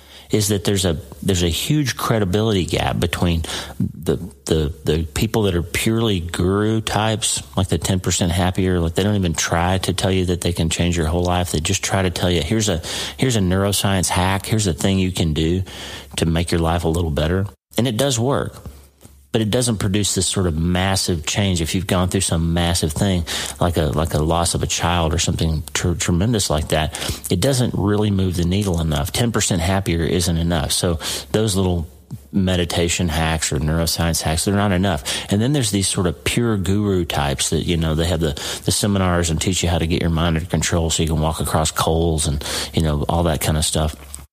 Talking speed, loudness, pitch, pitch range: 220 wpm, -19 LUFS, 90 Hz, 80-100 Hz